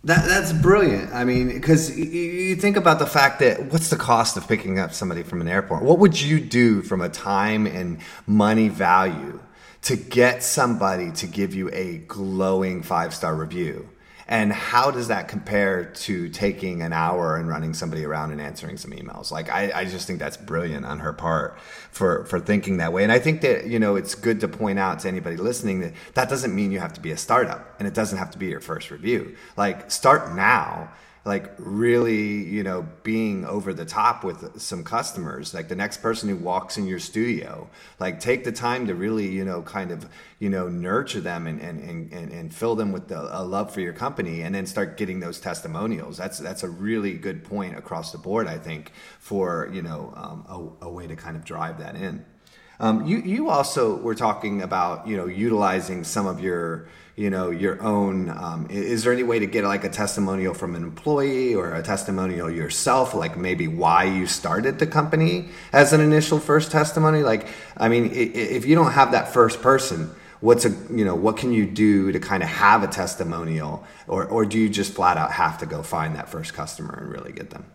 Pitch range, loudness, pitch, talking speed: 90-125 Hz, -22 LUFS, 105 Hz, 215 wpm